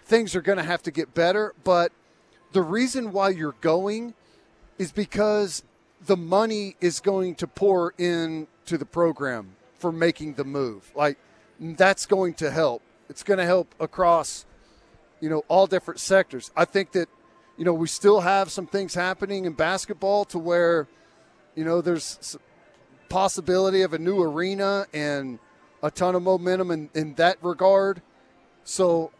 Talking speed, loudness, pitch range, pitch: 160 wpm, -24 LUFS, 165-195 Hz, 175 Hz